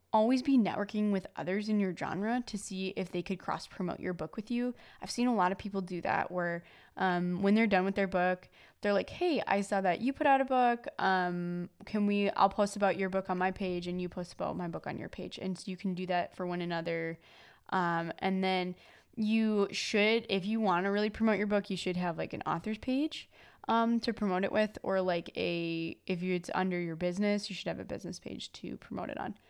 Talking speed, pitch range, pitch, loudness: 240 wpm, 180-215 Hz, 190 Hz, -33 LUFS